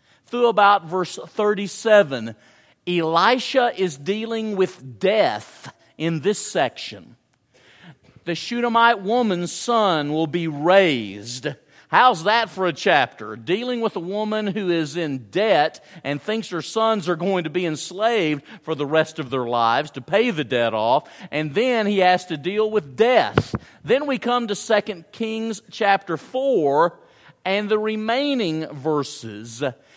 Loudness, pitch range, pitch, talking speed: -21 LUFS, 150-215 Hz, 180 Hz, 145 wpm